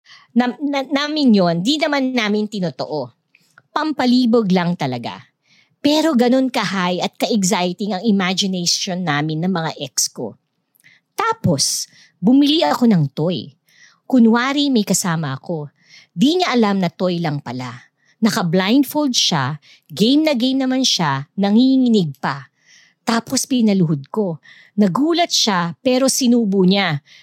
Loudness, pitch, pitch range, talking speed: -17 LUFS, 210 Hz, 175-255 Hz, 125 wpm